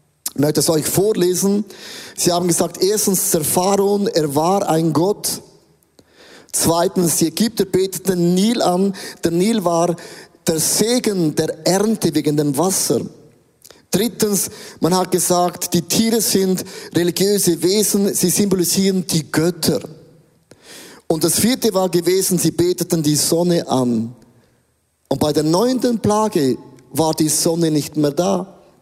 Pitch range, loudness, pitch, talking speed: 160-195 Hz, -17 LUFS, 175 Hz, 130 wpm